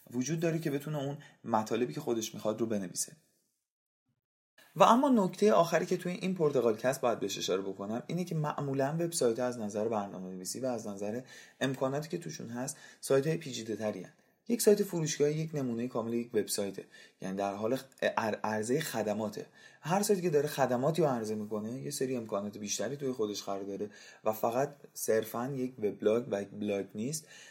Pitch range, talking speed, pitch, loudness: 110-155 Hz, 170 wpm, 130 Hz, -33 LUFS